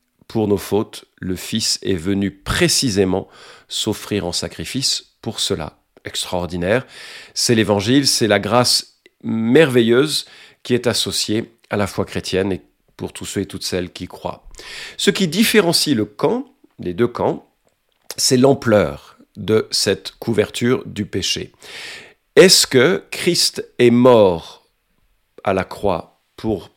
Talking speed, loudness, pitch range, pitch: 135 wpm, -17 LUFS, 95-130 Hz, 110 Hz